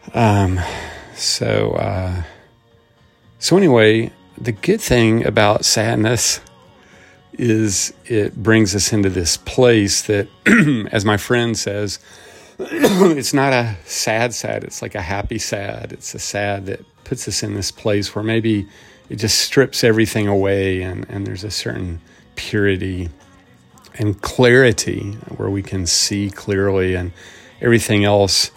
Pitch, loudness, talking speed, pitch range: 105 Hz, -17 LUFS, 135 wpm, 95-115 Hz